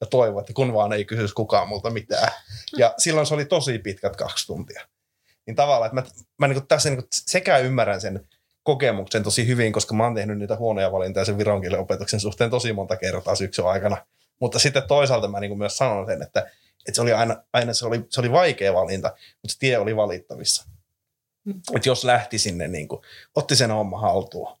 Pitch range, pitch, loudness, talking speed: 100-130 Hz, 115 Hz, -22 LUFS, 200 wpm